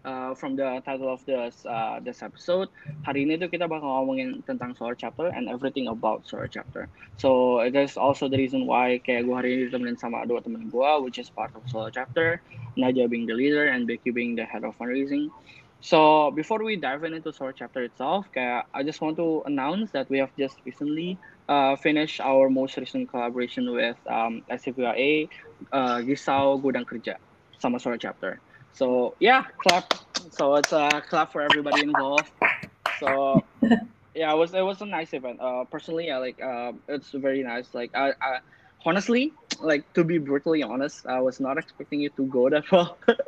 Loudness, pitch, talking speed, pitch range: -26 LUFS, 135 Hz, 175 wpm, 125-160 Hz